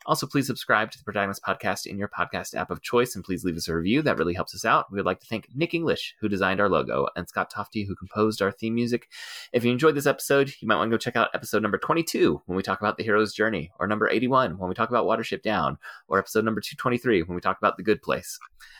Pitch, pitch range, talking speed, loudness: 110 Hz, 95-120 Hz, 270 wpm, -25 LUFS